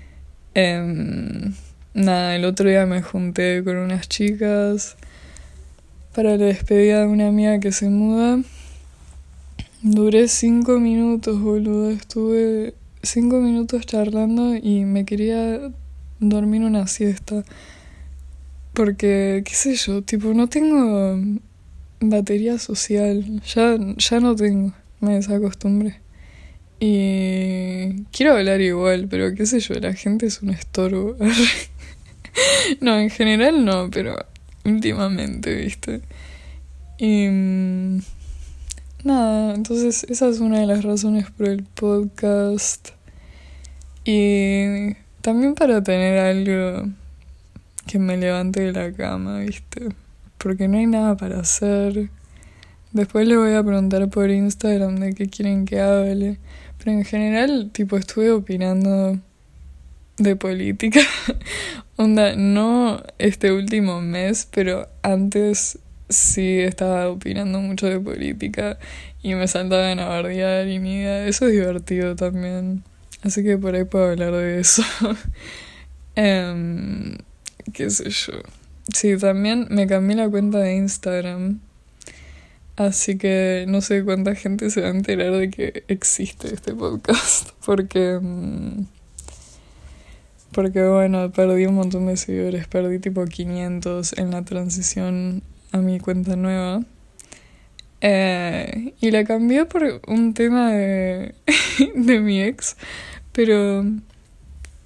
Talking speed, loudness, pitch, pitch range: 120 wpm, -20 LUFS, 195 Hz, 180-210 Hz